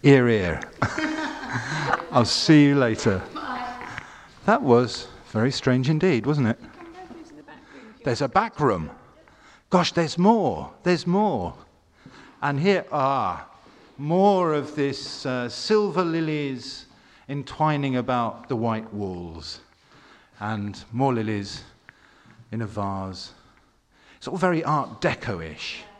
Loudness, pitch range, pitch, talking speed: -24 LUFS, 110-170 Hz, 130 Hz, 115 wpm